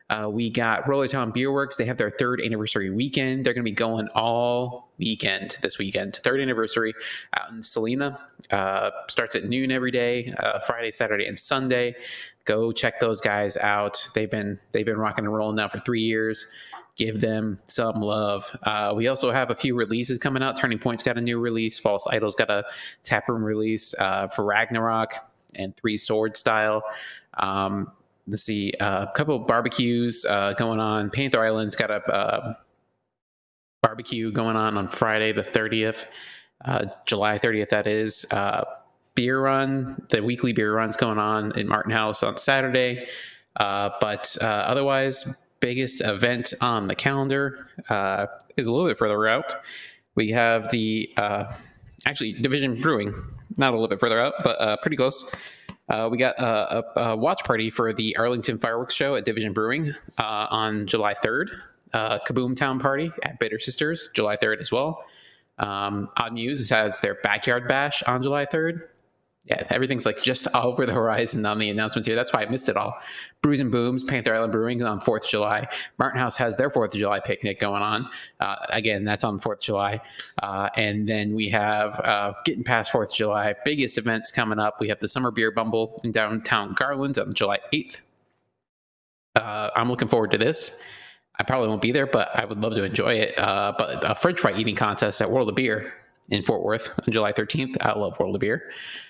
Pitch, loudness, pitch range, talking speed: 115 Hz, -24 LUFS, 105-125 Hz, 190 wpm